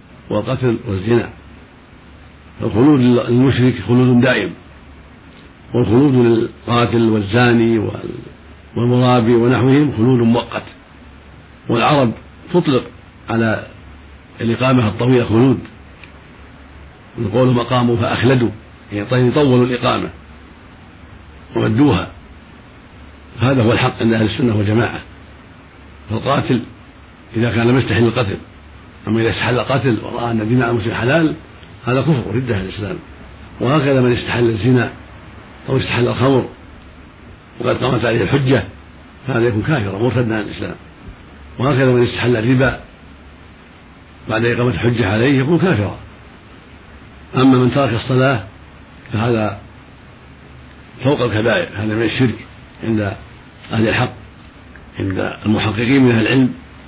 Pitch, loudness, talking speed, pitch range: 115 Hz, -16 LUFS, 100 wpm, 95-125 Hz